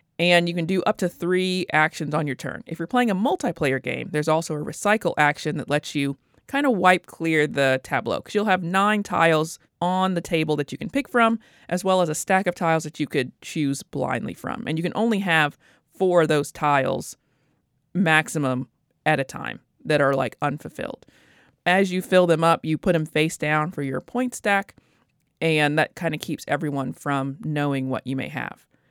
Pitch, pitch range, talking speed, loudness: 160 Hz, 145-185 Hz, 210 wpm, -23 LUFS